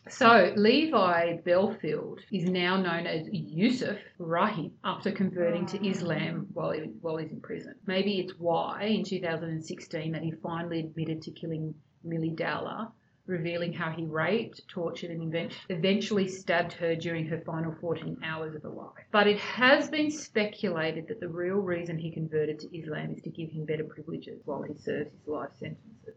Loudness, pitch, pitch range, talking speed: -30 LUFS, 170 Hz, 160-195 Hz, 170 wpm